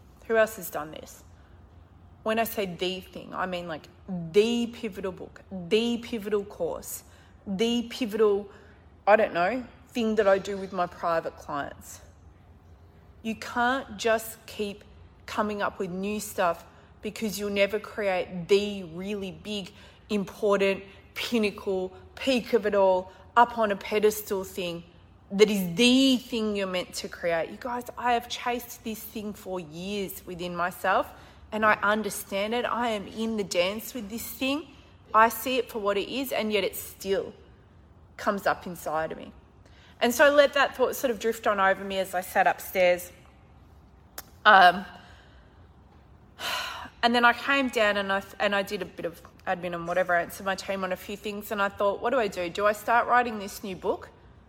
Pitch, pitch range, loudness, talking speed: 205 Hz, 185-225 Hz, -27 LUFS, 175 wpm